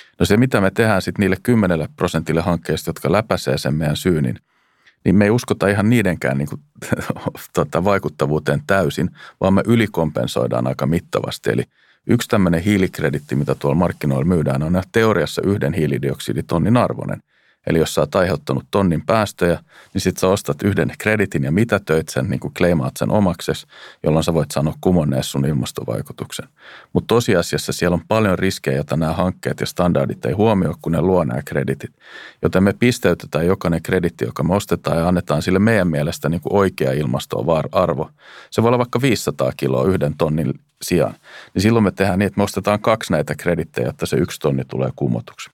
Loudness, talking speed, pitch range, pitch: -19 LUFS, 175 wpm, 75-95 Hz, 85 Hz